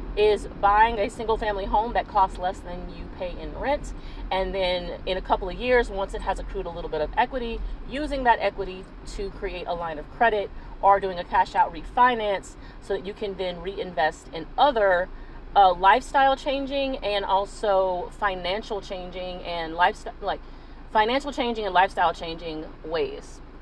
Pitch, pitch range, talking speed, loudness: 195 Hz, 180-225 Hz, 175 wpm, -25 LUFS